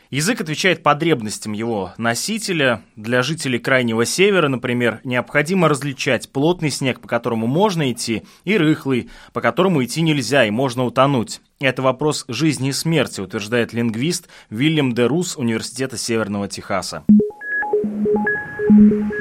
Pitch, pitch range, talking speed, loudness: 135 Hz, 120-165 Hz, 120 wpm, -18 LUFS